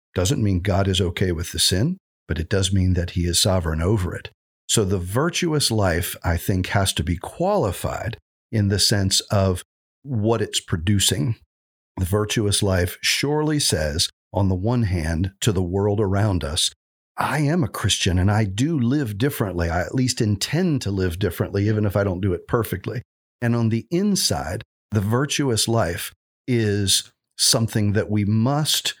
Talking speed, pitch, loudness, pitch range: 175 wpm, 105 Hz, -21 LUFS, 95-115 Hz